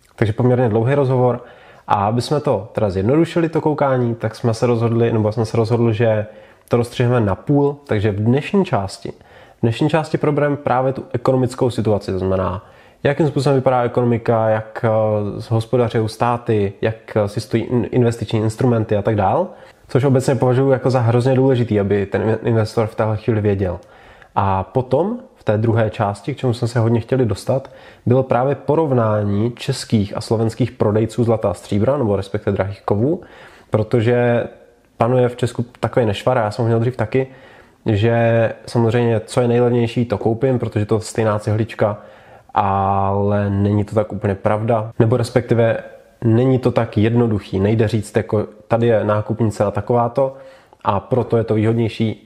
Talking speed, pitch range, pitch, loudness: 165 wpm, 105-125 Hz, 115 Hz, -18 LUFS